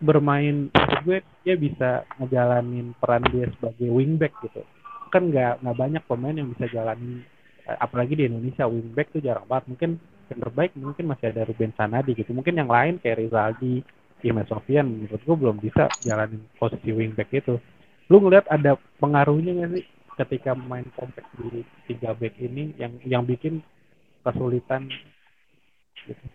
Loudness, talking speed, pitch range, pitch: -24 LUFS, 155 wpm, 120-150 Hz, 125 Hz